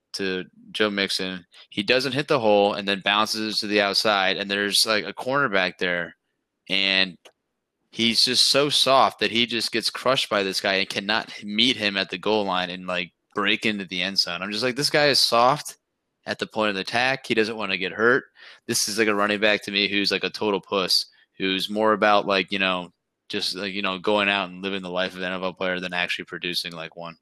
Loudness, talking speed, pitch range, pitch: -22 LUFS, 230 wpm, 95-110 Hz, 100 Hz